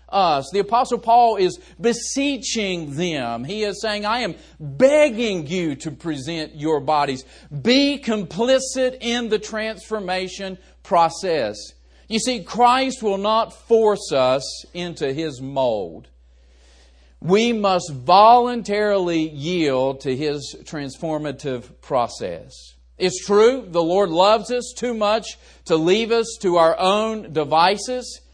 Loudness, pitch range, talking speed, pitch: -20 LUFS, 155-225 Hz, 120 wpm, 185 Hz